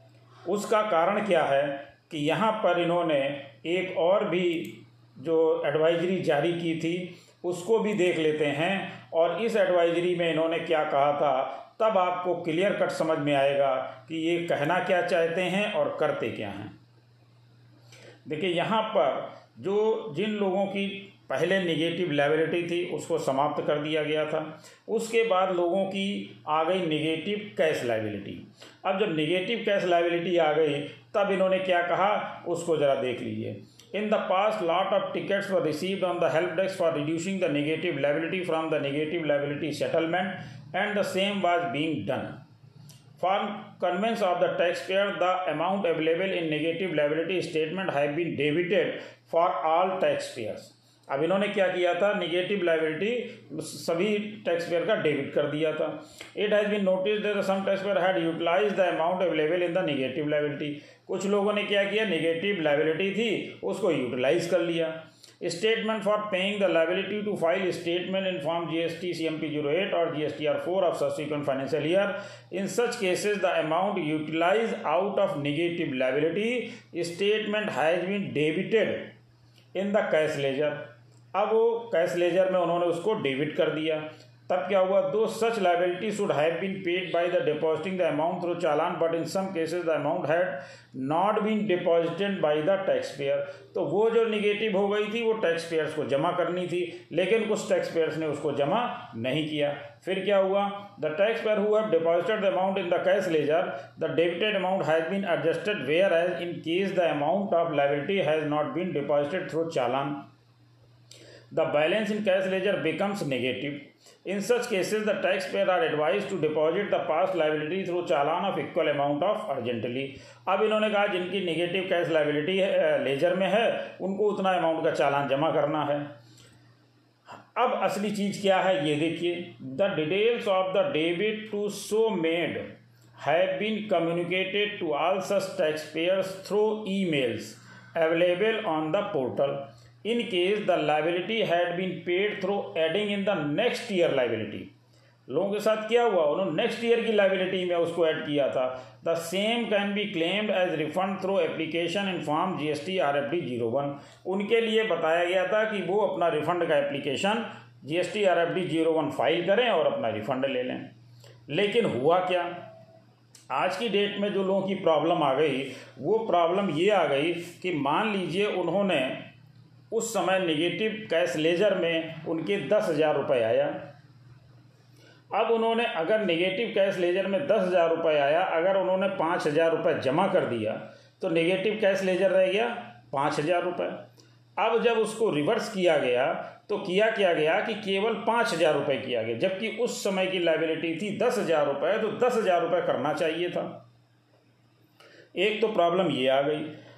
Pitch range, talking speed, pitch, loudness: 155-195 Hz, 175 wpm, 175 Hz, -27 LUFS